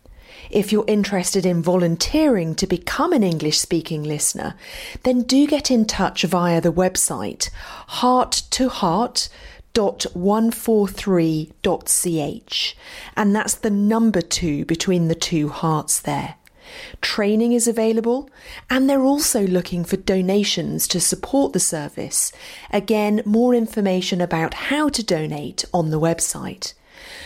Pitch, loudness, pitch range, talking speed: 200 Hz, -20 LUFS, 170-240 Hz, 120 wpm